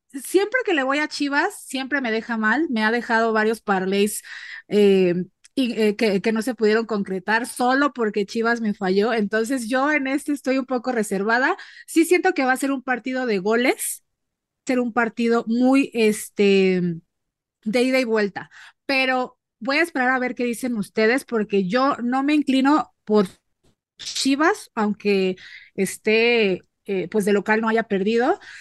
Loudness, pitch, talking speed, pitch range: -21 LUFS, 235 Hz, 170 wpm, 210-265 Hz